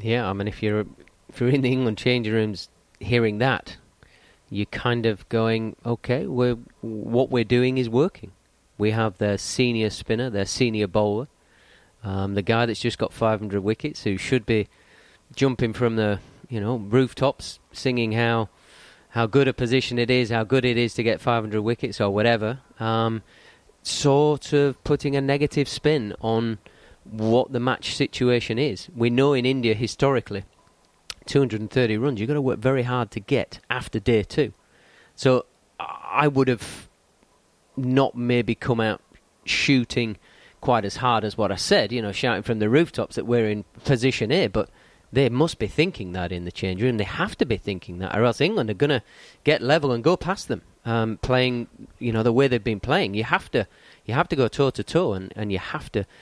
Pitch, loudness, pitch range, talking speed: 115 Hz, -23 LUFS, 105-130 Hz, 190 wpm